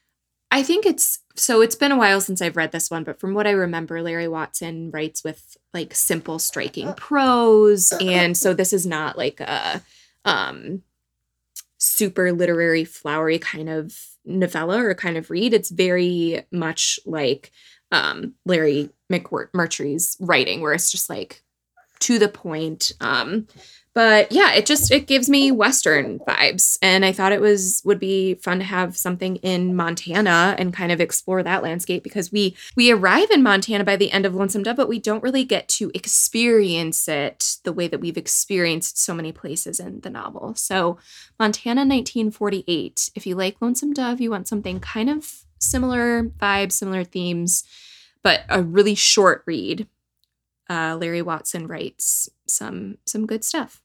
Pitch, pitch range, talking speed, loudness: 185 Hz, 170-215 Hz, 165 wpm, -19 LUFS